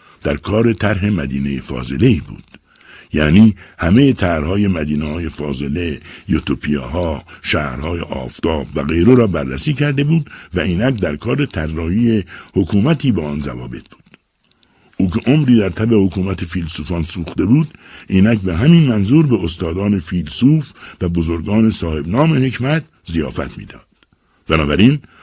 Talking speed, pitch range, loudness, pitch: 135 wpm, 80-115 Hz, -16 LUFS, 95 Hz